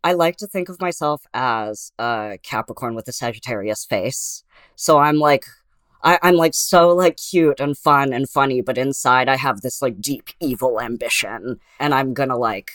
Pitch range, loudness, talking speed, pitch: 120-160 Hz, -19 LUFS, 185 wpm, 140 Hz